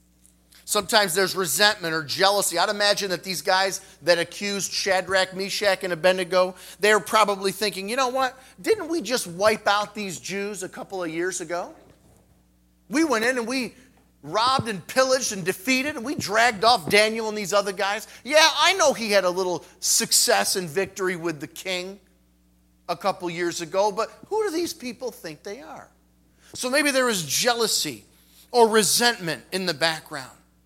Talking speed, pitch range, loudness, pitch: 175 wpm, 175-225 Hz, -22 LUFS, 195 Hz